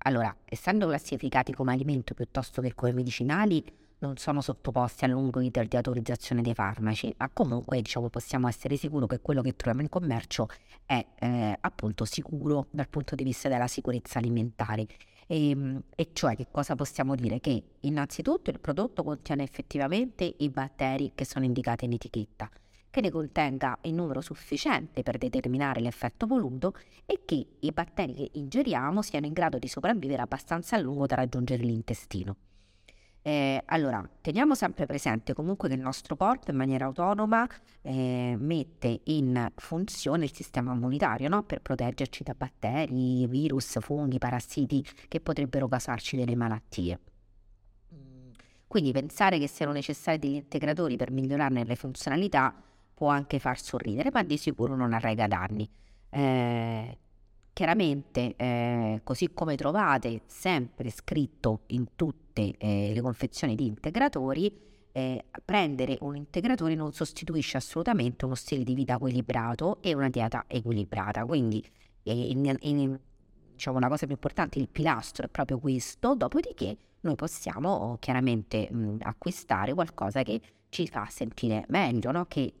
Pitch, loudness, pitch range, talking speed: 130 Hz, -30 LUFS, 120-150 Hz, 145 wpm